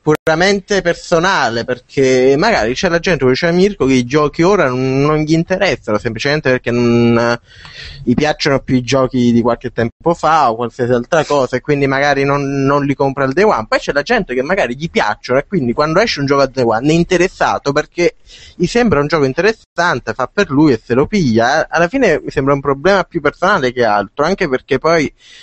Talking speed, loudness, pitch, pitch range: 210 wpm, -14 LUFS, 140 Hz, 125-170 Hz